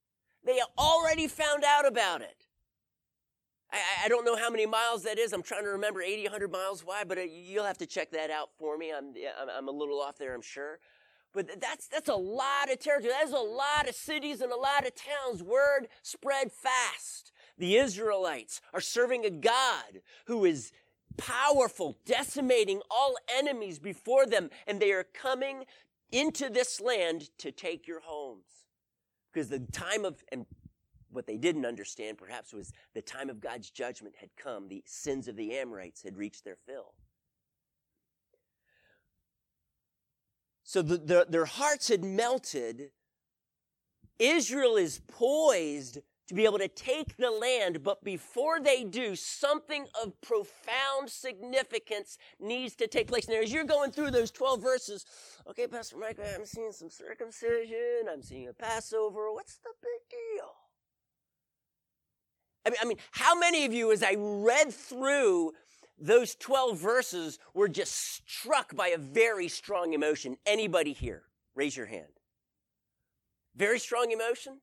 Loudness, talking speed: -31 LUFS, 160 wpm